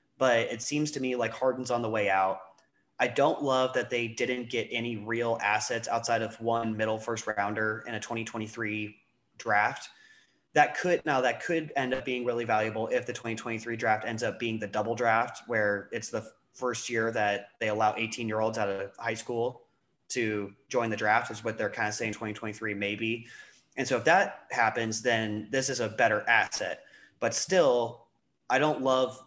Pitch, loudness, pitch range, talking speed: 115 Hz, -29 LUFS, 110-120 Hz, 190 wpm